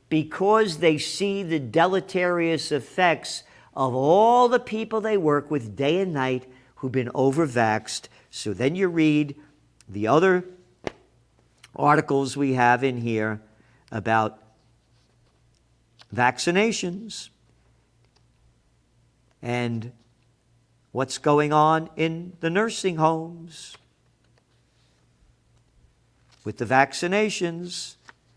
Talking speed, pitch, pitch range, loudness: 90 wpm, 140 Hz, 120-175 Hz, -23 LUFS